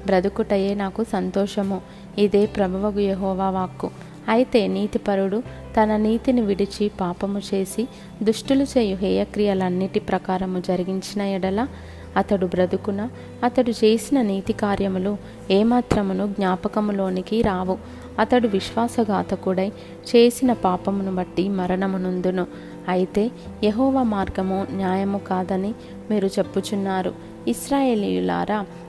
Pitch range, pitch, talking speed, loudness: 190-215 Hz, 200 Hz, 85 wpm, -22 LUFS